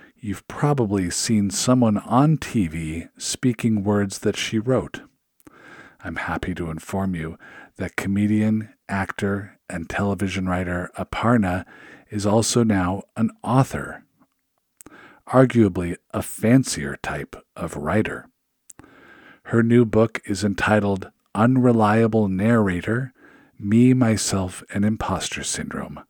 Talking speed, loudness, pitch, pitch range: 105 wpm, -22 LUFS, 105 Hz, 95-115 Hz